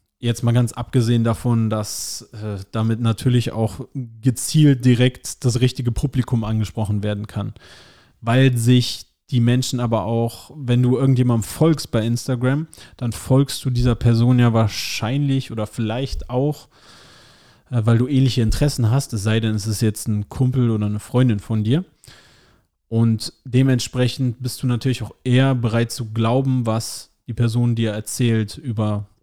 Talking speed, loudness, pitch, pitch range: 155 wpm, -20 LUFS, 120 Hz, 110-130 Hz